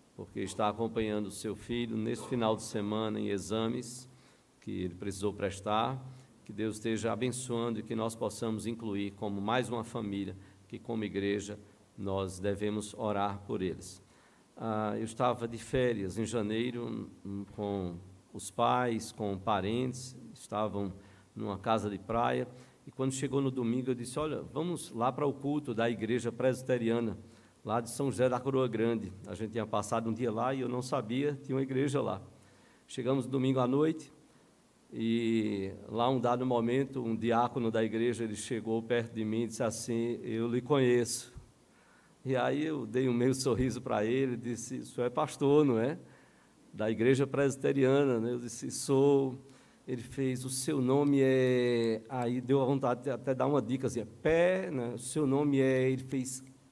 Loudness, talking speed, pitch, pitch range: -33 LUFS, 175 wpm, 120 Hz, 110-130 Hz